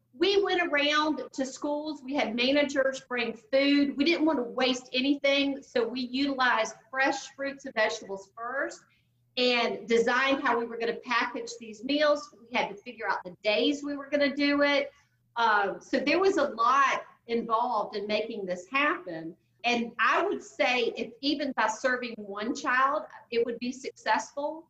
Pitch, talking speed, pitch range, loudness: 255 Hz, 175 wpm, 230-285 Hz, -28 LUFS